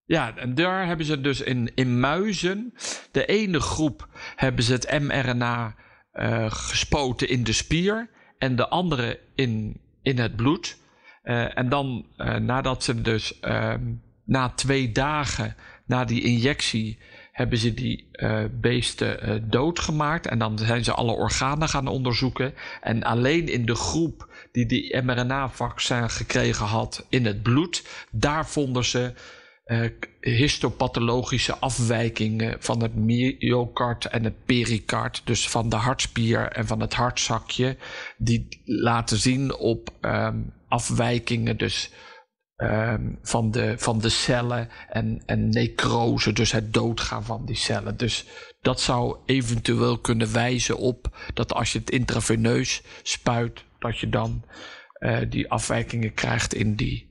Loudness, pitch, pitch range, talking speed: -25 LUFS, 120 Hz, 115-130 Hz, 140 wpm